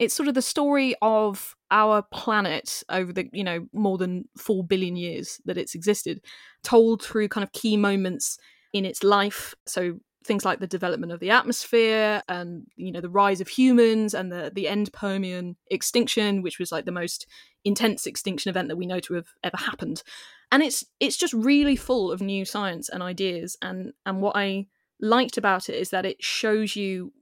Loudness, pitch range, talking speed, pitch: -25 LUFS, 185-225 Hz, 195 wpm, 200 Hz